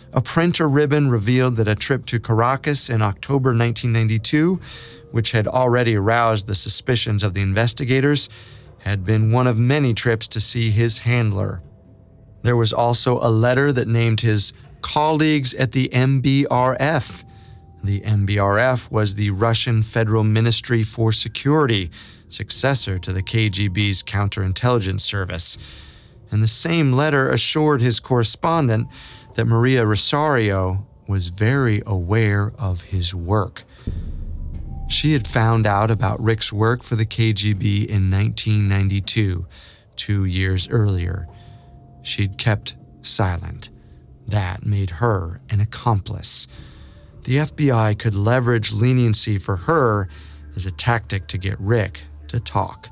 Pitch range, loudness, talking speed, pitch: 100-125 Hz, -19 LUFS, 125 wpm, 110 Hz